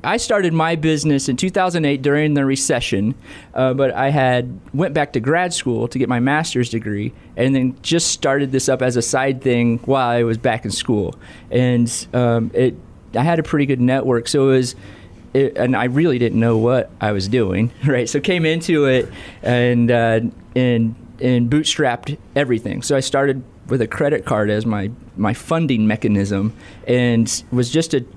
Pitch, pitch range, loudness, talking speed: 125 Hz, 115-140 Hz, -18 LUFS, 190 wpm